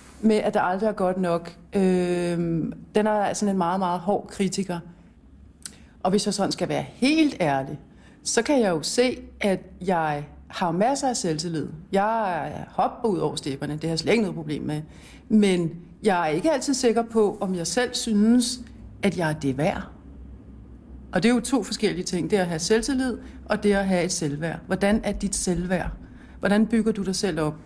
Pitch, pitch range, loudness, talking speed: 195 Hz, 170-220 Hz, -24 LUFS, 200 wpm